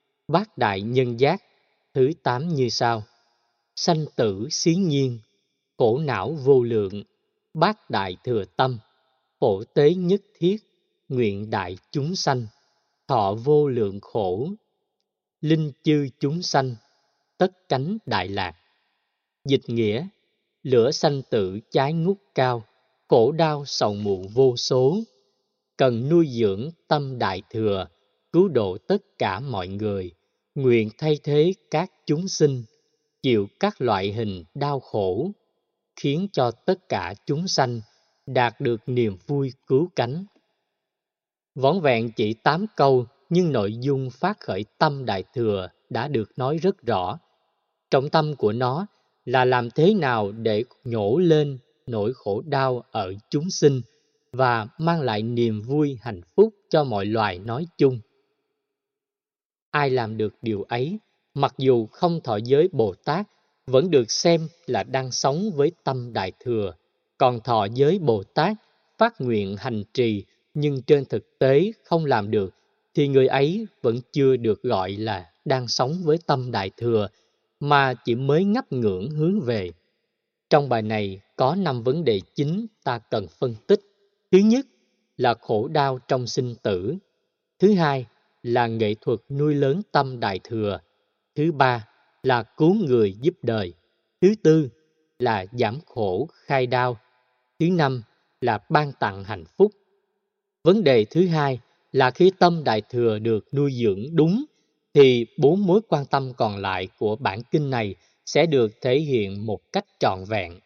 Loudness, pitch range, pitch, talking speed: -23 LUFS, 115-165 Hz, 135 Hz, 150 wpm